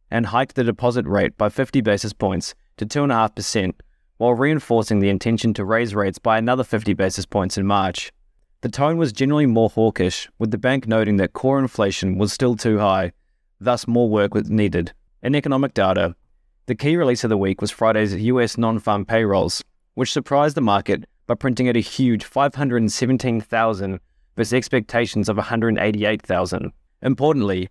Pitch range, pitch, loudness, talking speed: 100-125 Hz, 115 Hz, -20 LUFS, 165 wpm